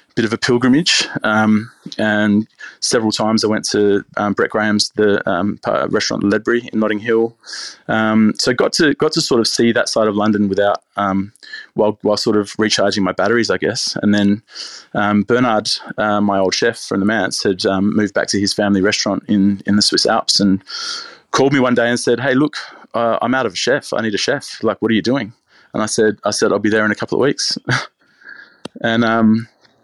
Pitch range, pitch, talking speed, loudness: 100-110 Hz, 105 Hz, 220 wpm, -16 LUFS